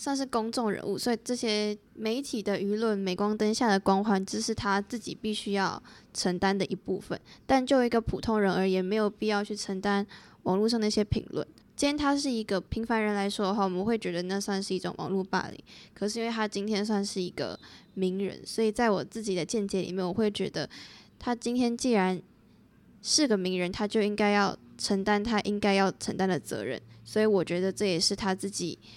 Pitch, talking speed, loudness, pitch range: 205 Hz, 310 characters per minute, -29 LUFS, 190-220 Hz